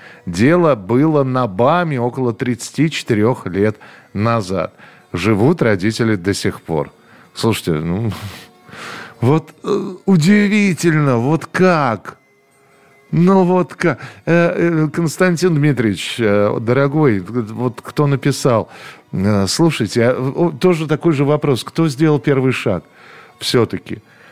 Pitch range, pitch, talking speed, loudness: 115-165 Hz, 135 Hz, 95 wpm, -16 LUFS